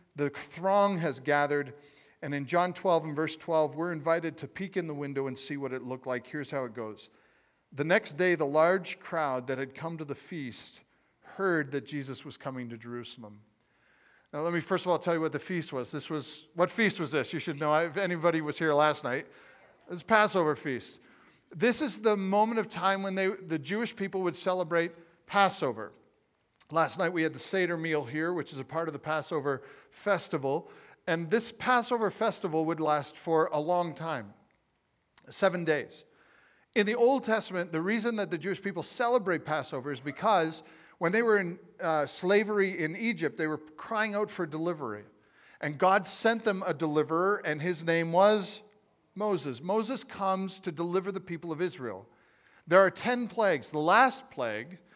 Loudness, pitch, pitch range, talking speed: -30 LUFS, 170 Hz, 150-195 Hz, 190 wpm